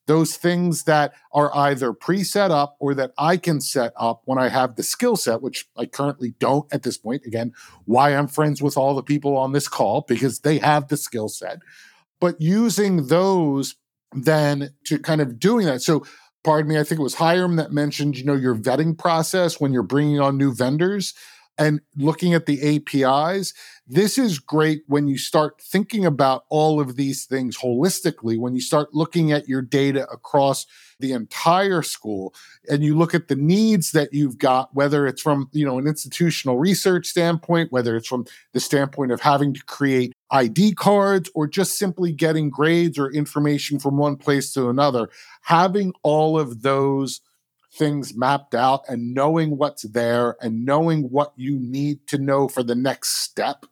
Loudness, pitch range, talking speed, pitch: -21 LUFS, 135-160 Hz, 185 wpm, 145 Hz